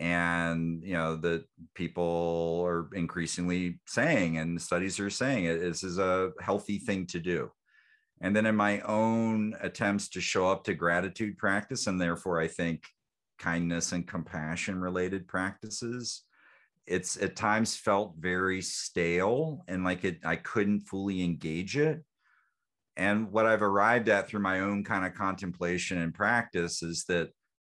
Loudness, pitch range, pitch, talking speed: -30 LUFS, 85-105 Hz, 95 Hz, 150 wpm